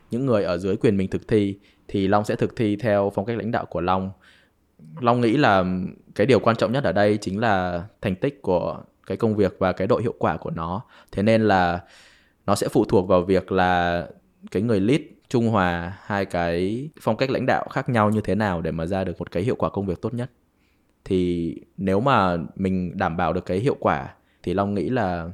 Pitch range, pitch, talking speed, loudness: 90-105 Hz, 95 Hz, 230 wpm, -23 LUFS